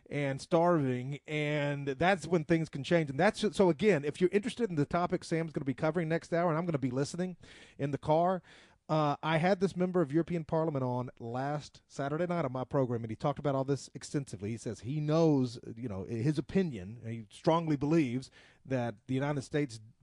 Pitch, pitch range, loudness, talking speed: 150 Hz, 130-170 Hz, -32 LUFS, 215 wpm